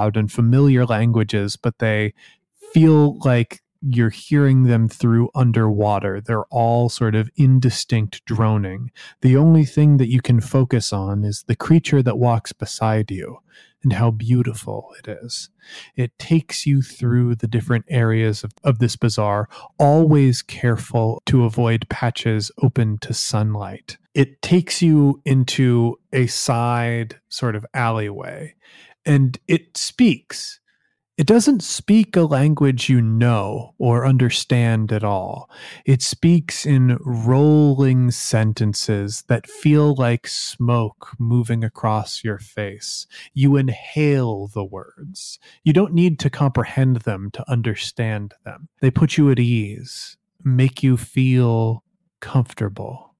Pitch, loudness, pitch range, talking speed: 120 Hz, -18 LUFS, 115-140 Hz, 130 wpm